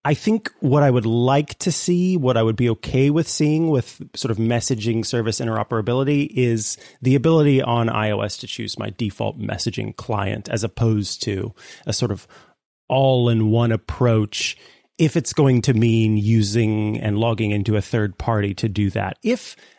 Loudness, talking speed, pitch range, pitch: -20 LUFS, 175 wpm, 110-135 Hz, 115 Hz